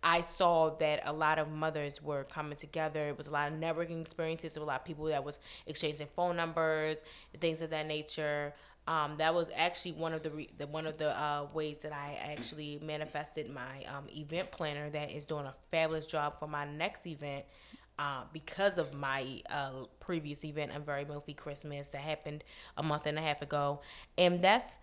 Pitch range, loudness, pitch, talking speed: 145-160 Hz, -36 LUFS, 150 Hz, 205 wpm